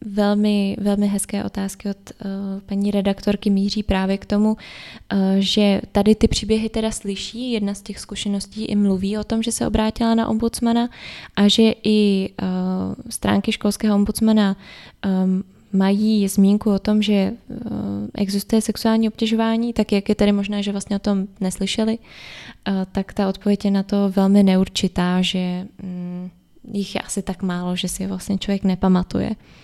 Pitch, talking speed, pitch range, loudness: 200 Hz, 150 wpm, 195-215 Hz, -20 LUFS